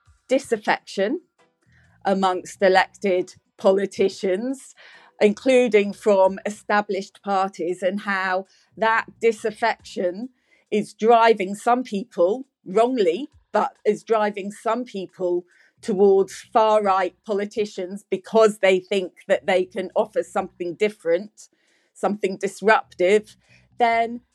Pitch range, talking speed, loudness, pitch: 190-225 Hz, 95 wpm, -22 LUFS, 205 Hz